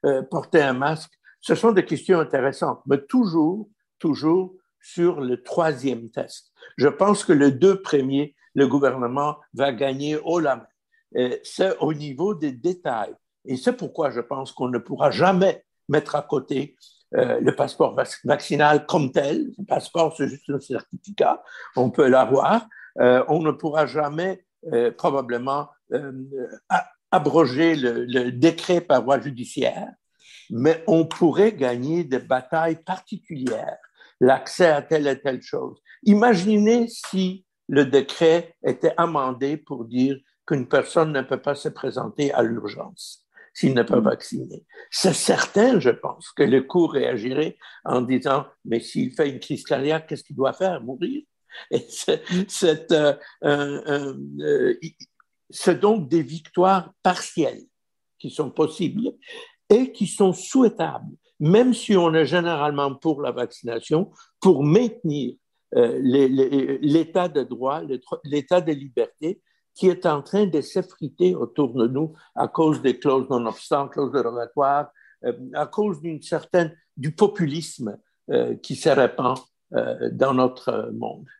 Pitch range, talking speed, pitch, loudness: 135-185 Hz, 145 wpm, 155 Hz, -22 LUFS